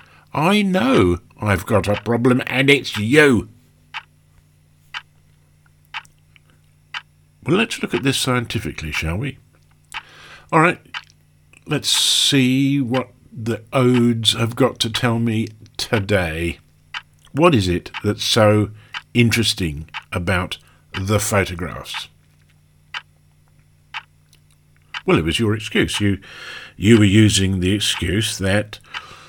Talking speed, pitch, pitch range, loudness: 105 wpm, 105 Hz, 80-120 Hz, -18 LUFS